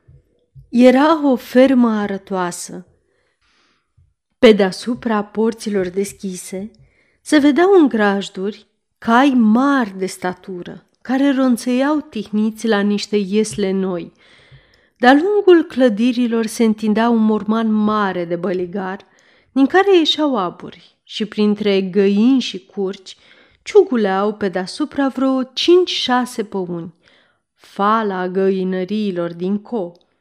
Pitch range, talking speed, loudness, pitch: 195-255 Hz, 105 wpm, -16 LUFS, 215 Hz